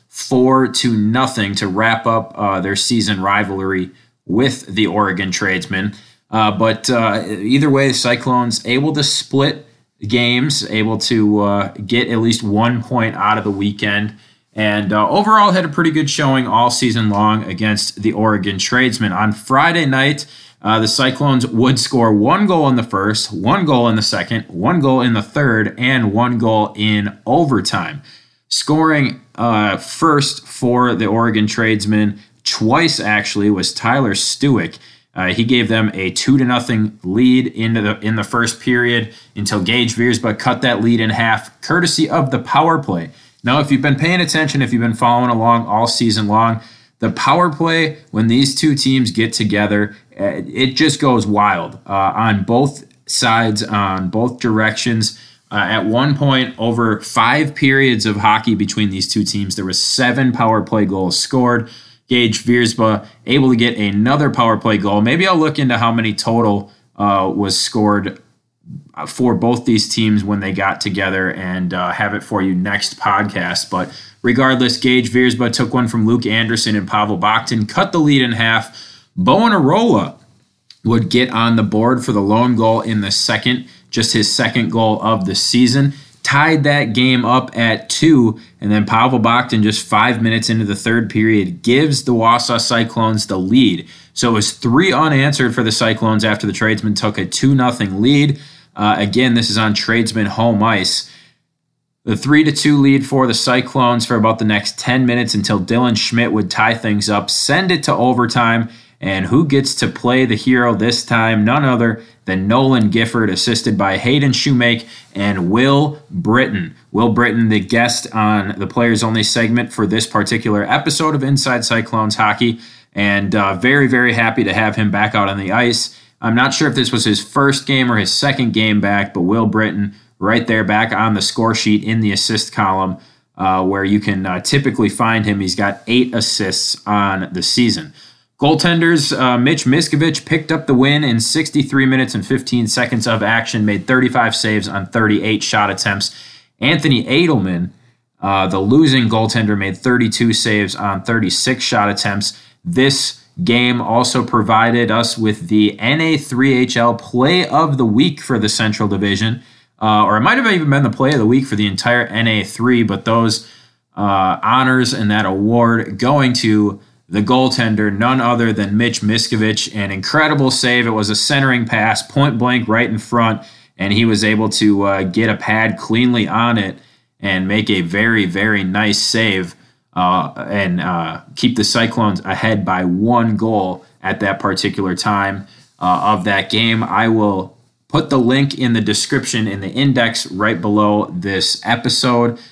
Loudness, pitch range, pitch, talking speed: -14 LUFS, 105-125 Hz, 115 Hz, 175 wpm